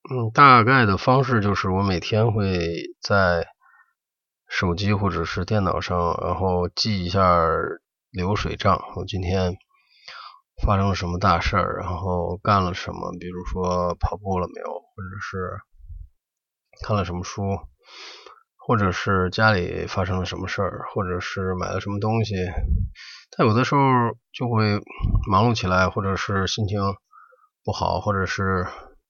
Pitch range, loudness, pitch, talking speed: 90-110 Hz, -22 LUFS, 95 Hz, 215 characters per minute